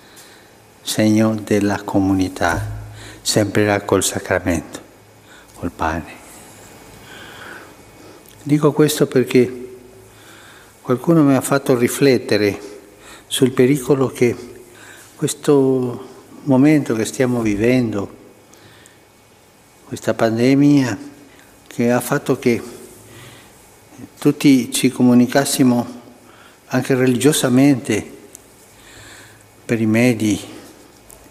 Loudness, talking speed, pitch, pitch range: -17 LUFS, 75 wpm, 120 Hz, 105-130 Hz